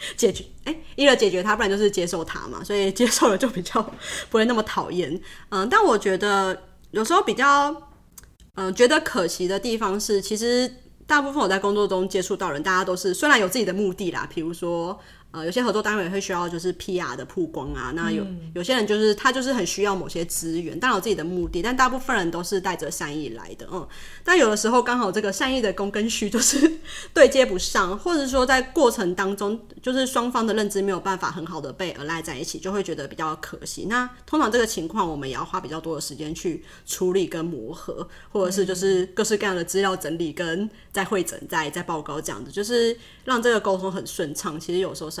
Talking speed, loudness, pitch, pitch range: 340 characters per minute, -23 LUFS, 195 Hz, 175-230 Hz